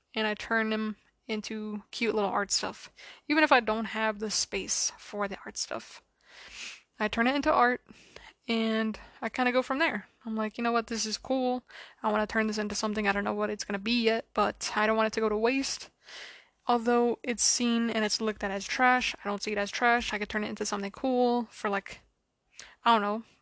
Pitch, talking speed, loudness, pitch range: 220 Hz, 235 wpm, -29 LUFS, 210-240 Hz